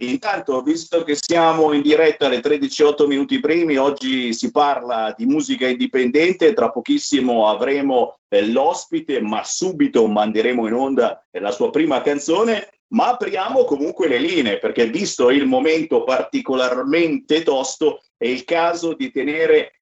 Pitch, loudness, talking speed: 155 Hz, -18 LUFS, 135 wpm